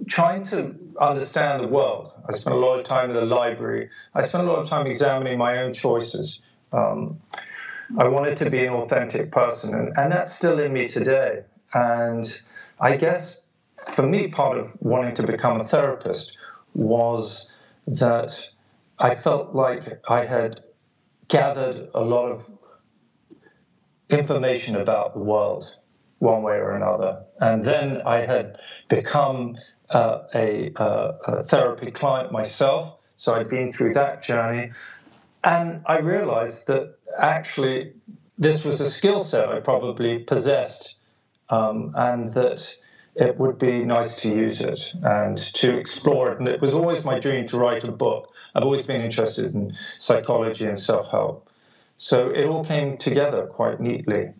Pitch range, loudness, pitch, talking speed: 115-145 Hz, -23 LUFS, 130 Hz, 155 wpm